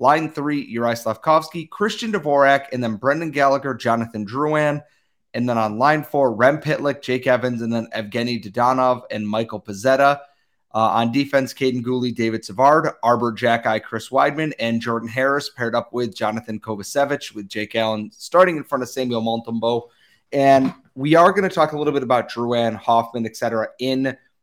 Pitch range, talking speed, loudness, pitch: 115-140 Hz, 170 wpm, -20 LUFS, 125 Hz